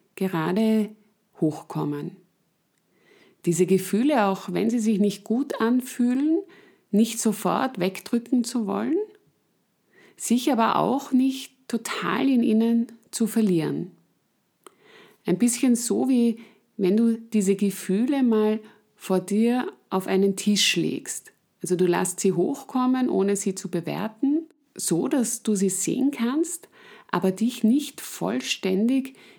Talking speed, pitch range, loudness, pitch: 120 wpm, 195-255 Hz, -24 LUFS, 220 Hz